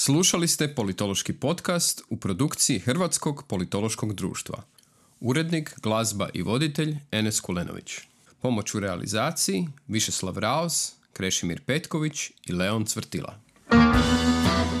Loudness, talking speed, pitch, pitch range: -25 LUFS, 100 wpm, 115 Hz, 100-155 Hz